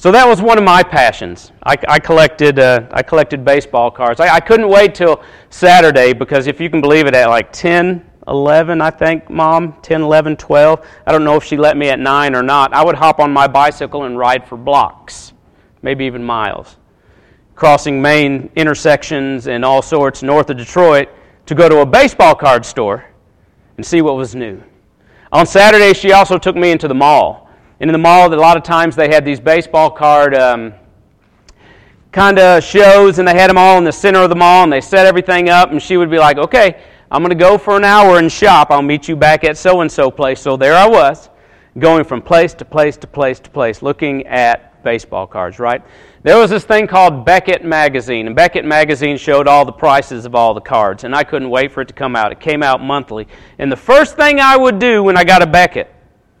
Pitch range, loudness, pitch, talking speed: 135-175 Hz, -10 LUFS, 150 Hz, 220 wpm